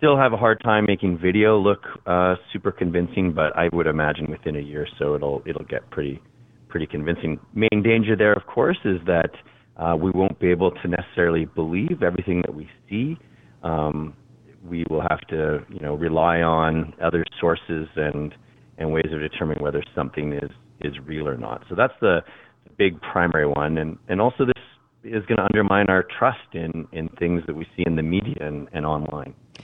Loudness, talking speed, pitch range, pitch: -23 LUFS, 195 wpm, 75-100 Hz, 85 Hz